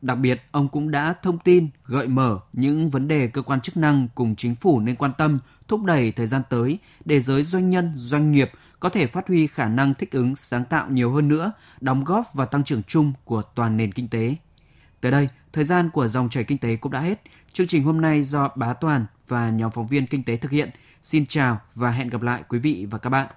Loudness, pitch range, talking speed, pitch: -22 LUFS, 125-150 Hz, 245 wpm, 135 Hz